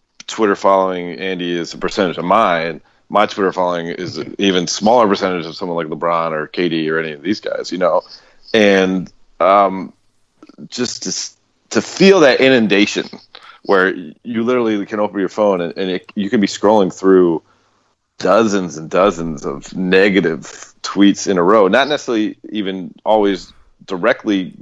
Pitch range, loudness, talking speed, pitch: 85-105 Hz, -15 LUFS, 160 wpm, 95 Hz